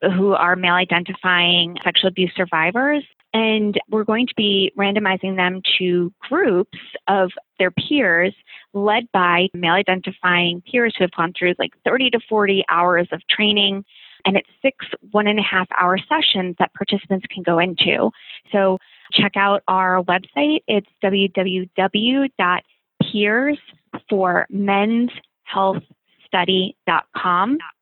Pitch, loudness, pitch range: 190 Hz, -18 LUFS, 180-210 Hz